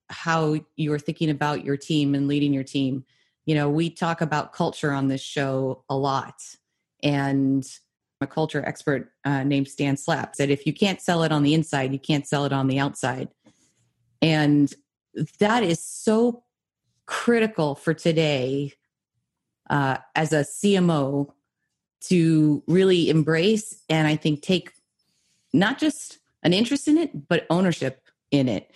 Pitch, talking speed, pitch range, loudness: 150 Hz, 150 wpm, 140-165 Hz, -23 LUFS